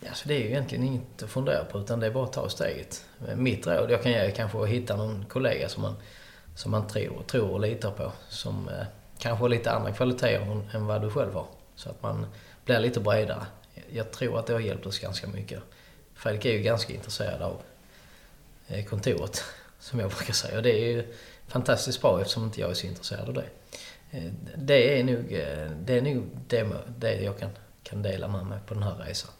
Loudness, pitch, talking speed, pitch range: -29 LUFS, 110 Hz, 210 wpm, 100-120 Hz